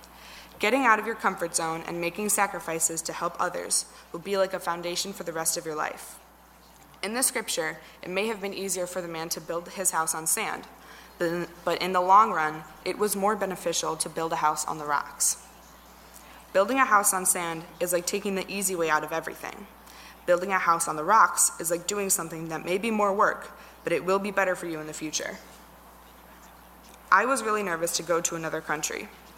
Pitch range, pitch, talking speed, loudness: 165-195 Hz, 175 Hz, 210 wpm, -26 LUFS